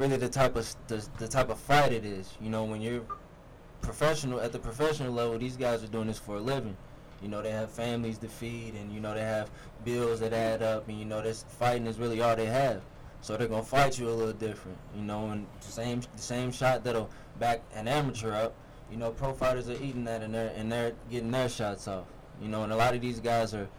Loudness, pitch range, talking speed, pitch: -32 LUFS, 110-125 Hz, 245 wpm, 115 Hz